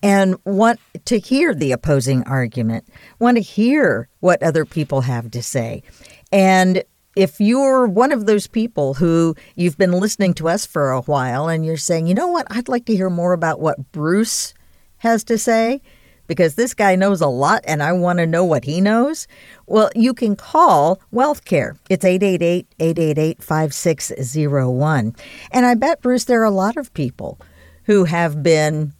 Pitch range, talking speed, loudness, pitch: 155-220 Hz, 175 wpm, -17 LUFS, 180 Hz